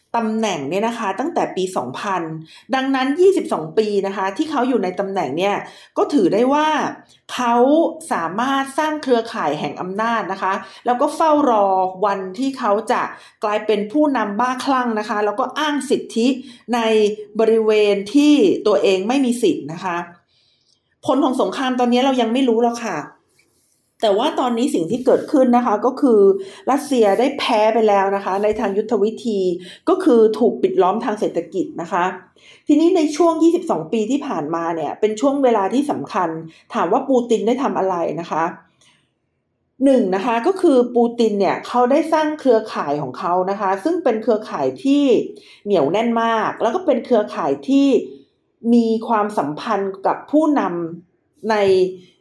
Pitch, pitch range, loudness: 225 Hz, 195-265 Hz, -18 LUFS